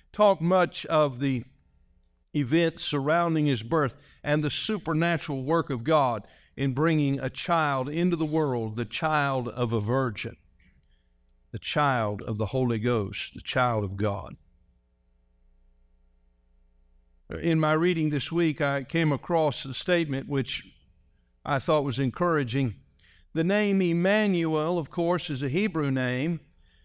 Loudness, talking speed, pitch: -27 LUFS, 135 wpm, 135 Hz